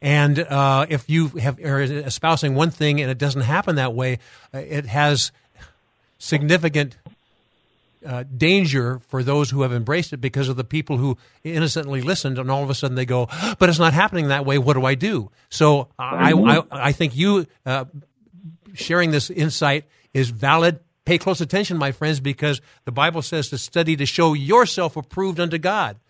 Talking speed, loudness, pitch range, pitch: 180 wpm, -20 LUFS, 135-165 Hz, 145 Hz